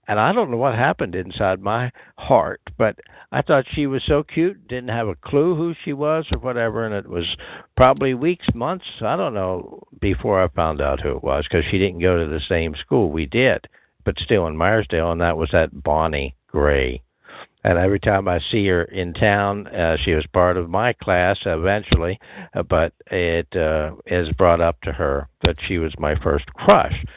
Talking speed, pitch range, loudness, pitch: 200 wpm, 85-115 Hz, -20 LUFS, 95 Hz